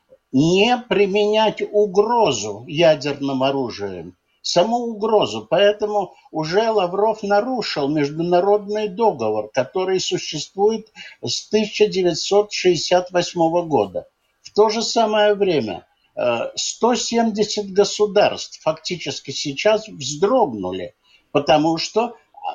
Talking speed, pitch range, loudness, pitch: 80 wpm, 155-215 Hz, -19 LUFS, 200 Hz